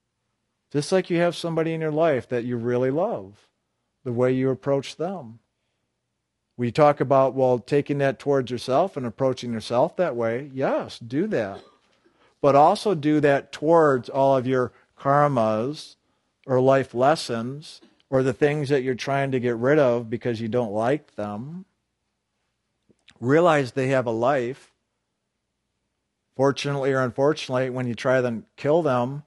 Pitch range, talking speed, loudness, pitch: 120-145 Hz, 150 wpm, -23 LUFS, 130 Hz